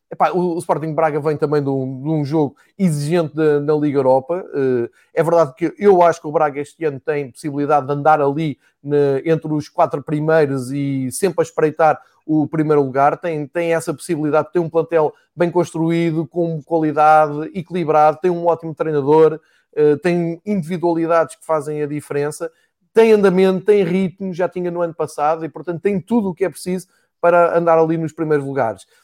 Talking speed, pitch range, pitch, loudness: 180 wpm, 150-175 Hz, 160 Hz, -18 LUFS